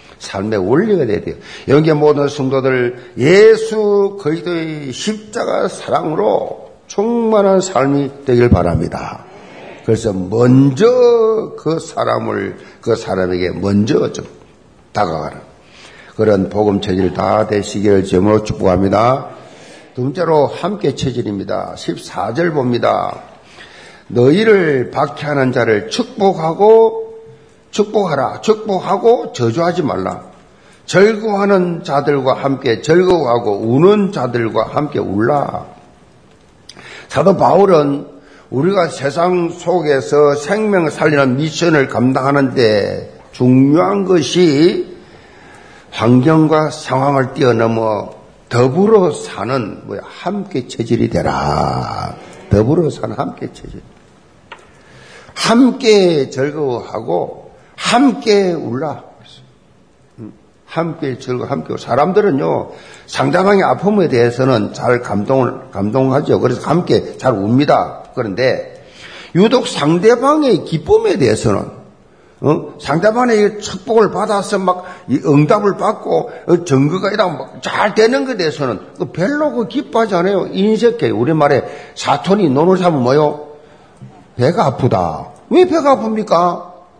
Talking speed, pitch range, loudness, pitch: 240 characters per minute, 130-205 Hz, -14 LUFS, 160 Hz